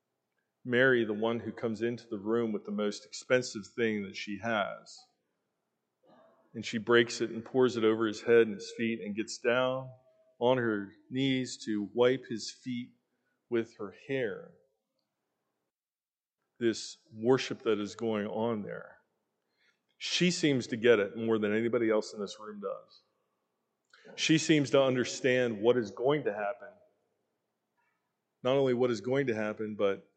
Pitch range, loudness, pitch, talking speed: 110-125 Hz, -31 LUFS, 115 Hz, 155 wpm